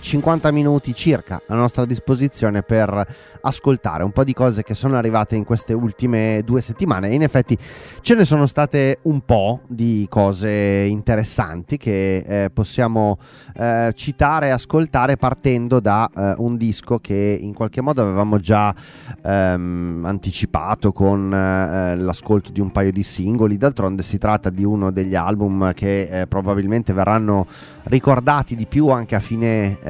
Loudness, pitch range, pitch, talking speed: -18 LUFS, 100-130 Hz, 110 Hz, 155 wpm